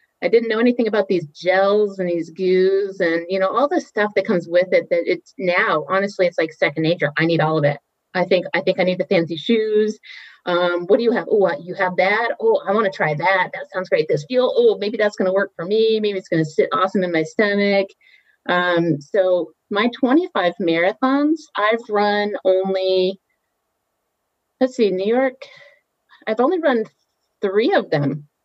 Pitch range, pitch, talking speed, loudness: 180-225 Hz, 195 Hz, 205 wpm, -19 LUFS